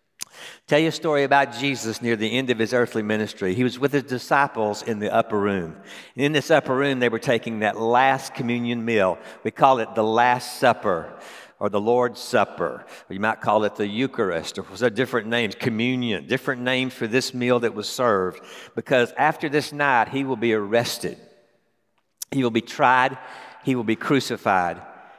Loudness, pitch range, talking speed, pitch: -22 LUFS, 110-135 Hz, 190 wpm, 125 Hz